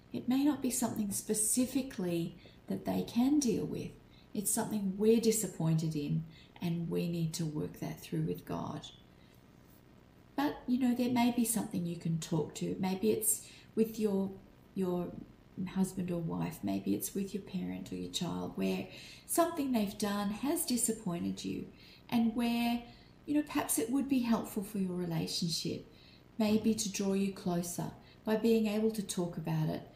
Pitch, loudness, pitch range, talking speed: 195 Hz, -34 LUFS, 165-230 Hz, 165 wpm